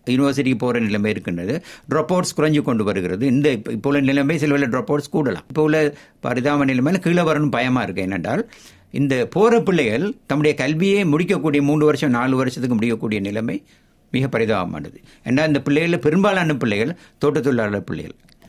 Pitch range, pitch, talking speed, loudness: 120-155 Hz, 140 Hz, 155 wpm, -19 LUFS